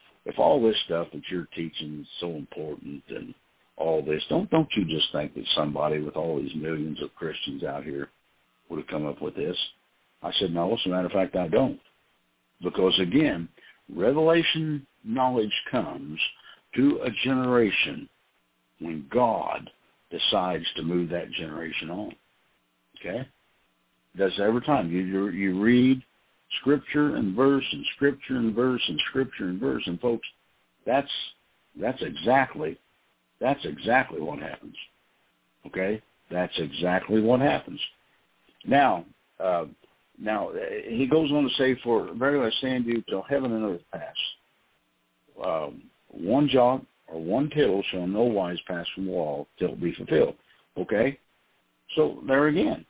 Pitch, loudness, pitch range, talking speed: 100 Hz, -26 LUFS, 80-130 Hz, 150 wpm